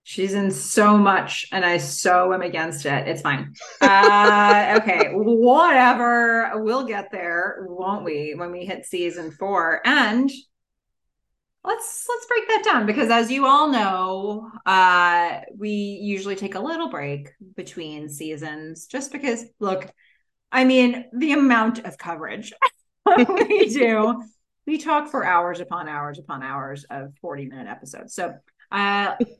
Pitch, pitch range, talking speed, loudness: 200 Hz, 175-245 Hz, 145 wpm, -19 LUFS